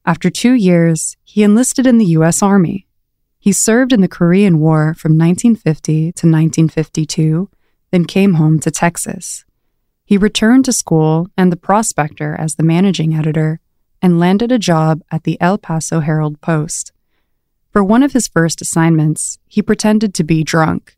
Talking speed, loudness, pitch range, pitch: 160 wpm, -13 LUFS, 160-205 Hz, 170 Hz